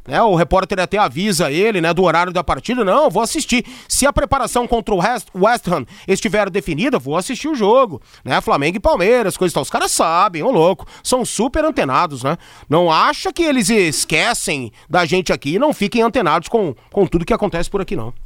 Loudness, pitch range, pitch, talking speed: -16 LUFS, 180-250 Hz, 205 Hz, 205 wpm